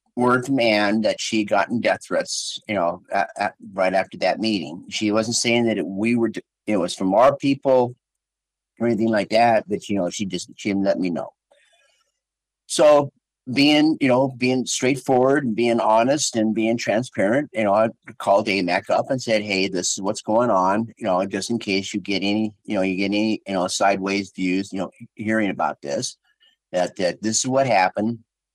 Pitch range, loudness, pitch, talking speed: 100-125 Hz, -21 LUFS, 110 Hz, 200 wpm